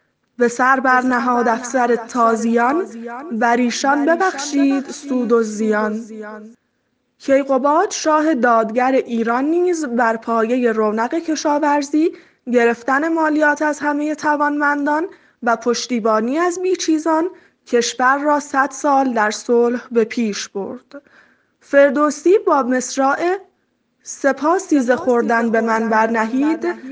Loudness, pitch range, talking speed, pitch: -17 LUFS, 235-300 Hz, 105 wpm, 260 Hz